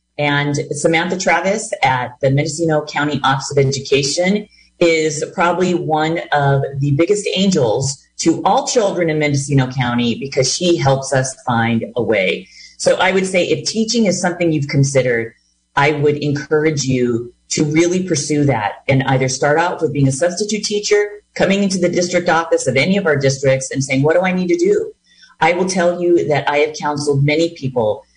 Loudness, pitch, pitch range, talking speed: -16 LUFS, 155 Hz, 135-175 Hz, 180 wpm